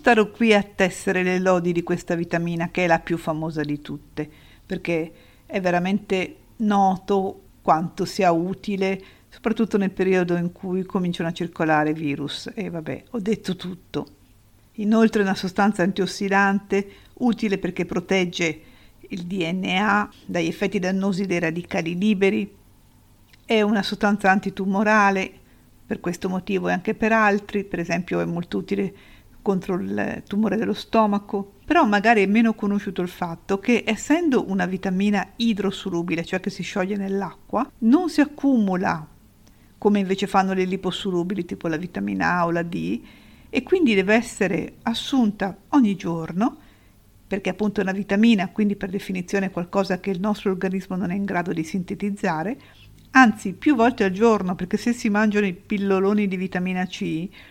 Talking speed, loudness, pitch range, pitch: 155 wpm, -22 LUFS, 175-210 Hz, 195 Hz